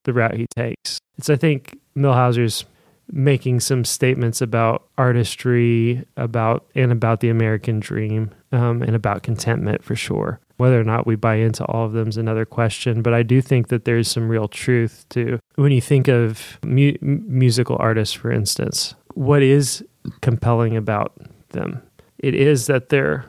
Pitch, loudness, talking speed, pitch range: 120 Hz, -19 LUFS, 170 wpm, 115-130 Hz